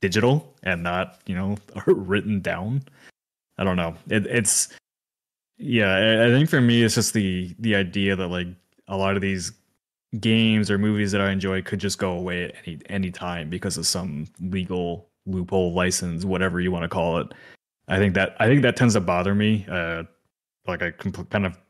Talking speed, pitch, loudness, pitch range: 195 wpm, 95 Hz, -23 LUFS, 90-105 Hz